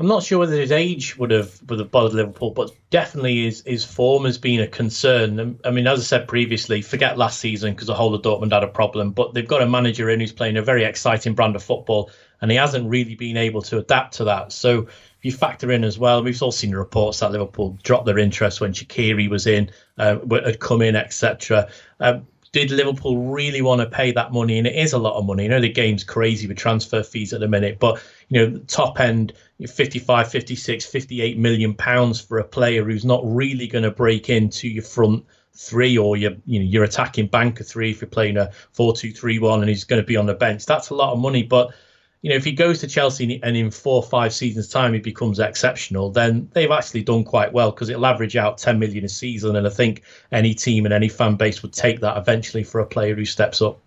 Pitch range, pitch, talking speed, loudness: 110-125 Hz, 115 Hz, 240 wpm, -20 LUFS